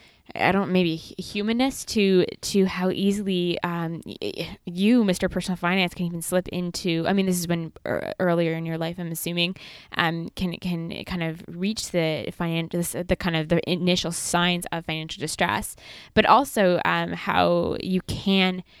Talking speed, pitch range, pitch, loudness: 165 wpm, 165-185 Hz, 175 Hz, -24 LUFS